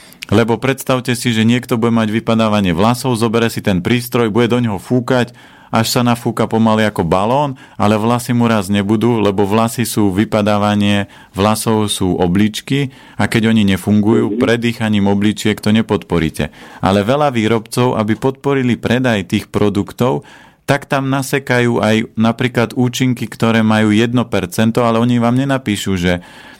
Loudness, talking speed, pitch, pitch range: -15 LUFS, 145 wpm, 115 Hz, 105-125 Hz